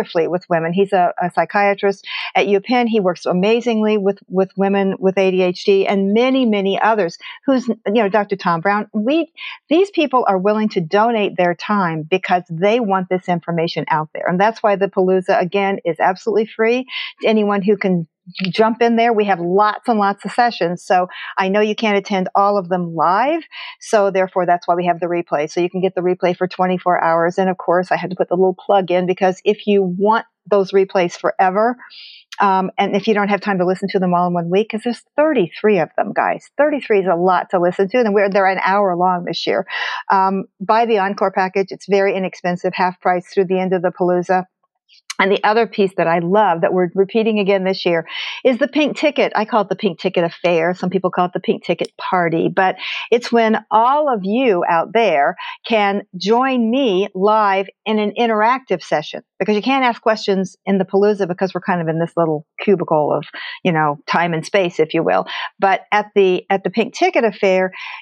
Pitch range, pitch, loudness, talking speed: 180-215 Hz, 195 Hz, -17 LUFS, 215 wpm